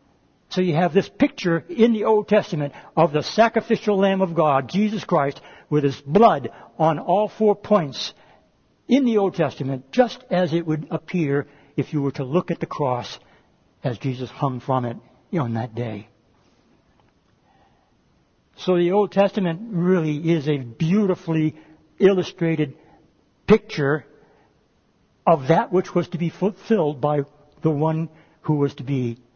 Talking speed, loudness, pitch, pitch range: 150 wpm, -22 LUFS, 160 Hz, 140-190 Hz